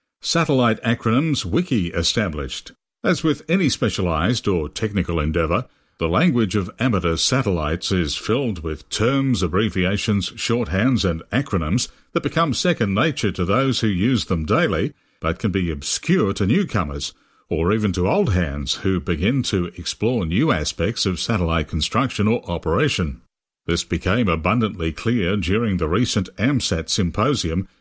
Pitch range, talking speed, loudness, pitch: 85-120 Hz, 140 wpm, -21 LUFS, 95 Hz